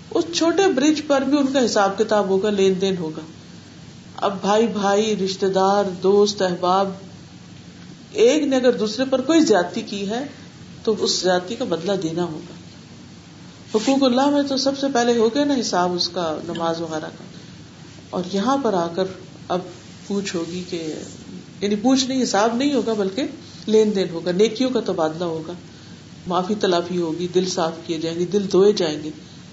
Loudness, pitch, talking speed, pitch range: -20 LUFS, 195 Hz, 175 wpm, 175-235 Hz